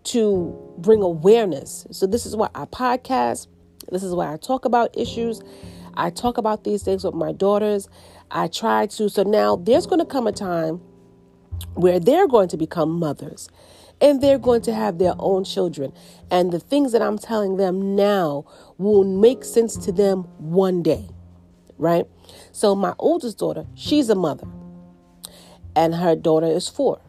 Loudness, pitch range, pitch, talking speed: -20 LUFS, 160-215 Hz, 190 Hz, 170 wpm